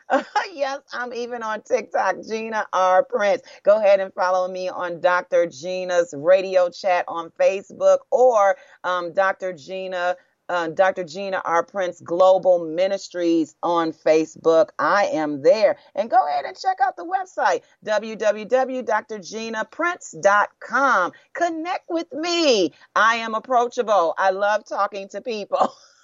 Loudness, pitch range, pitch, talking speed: -21 LUFS, 180-275 Hz, 205 Hz, 130 wpm